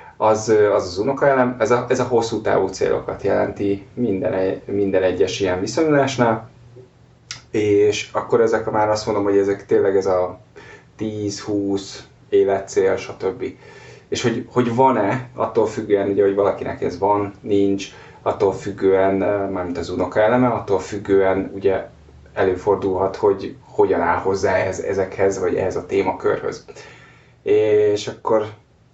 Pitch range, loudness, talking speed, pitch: 100-140 Hz, -19 LUFS, 135 wpm, 110 Hz